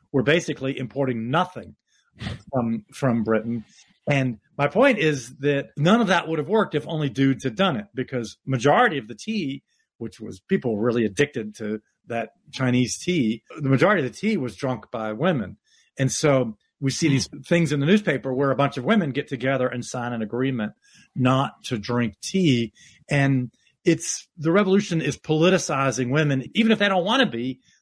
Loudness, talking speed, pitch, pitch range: -23 LUFS, 185 wpm, 135 Hz, 125-165 Hz